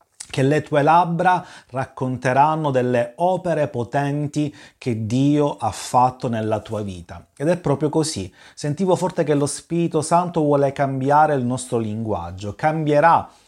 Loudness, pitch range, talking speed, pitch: -20 LUFS, 125-155 Hz, 140 wpm, 145 Hz